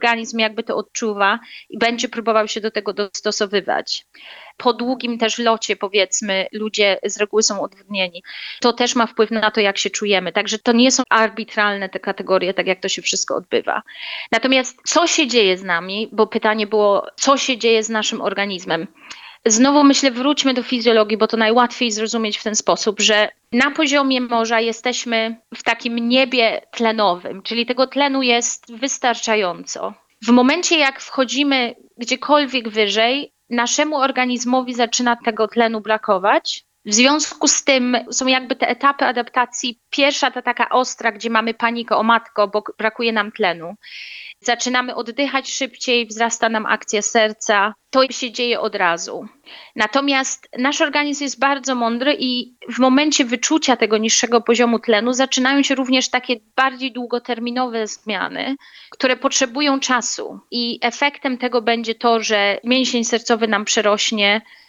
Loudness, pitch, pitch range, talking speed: -18 LUFS, 235 Hz, 220-260 Hz, 150 wpm